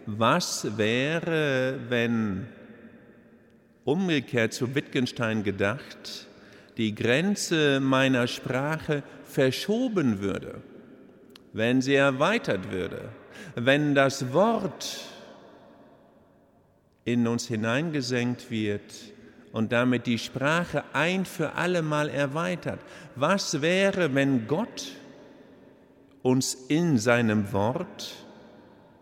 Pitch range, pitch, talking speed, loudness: 115-155 Hz, 135 Hz, 85 wpm, -26 LUFS